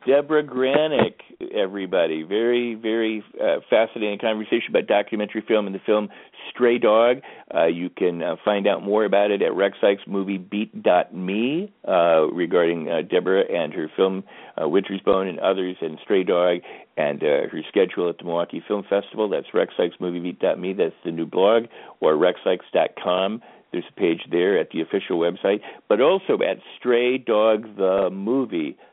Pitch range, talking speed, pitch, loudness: 95-120 Hz, 150 wpm, 105 Hz, -22 LUFS